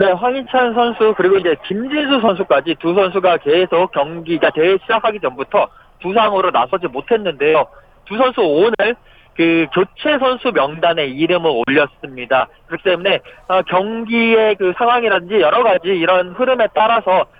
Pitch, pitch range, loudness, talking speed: 190 Hz, 170-230 Hz, -15 LUFS, 335 characters per minute